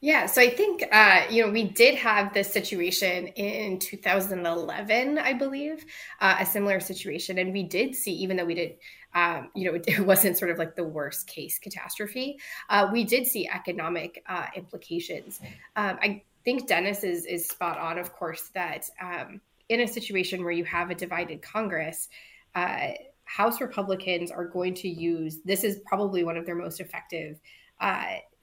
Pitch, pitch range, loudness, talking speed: 190 Hz, 175-220 Hz, -26 LUFS, 175 wpm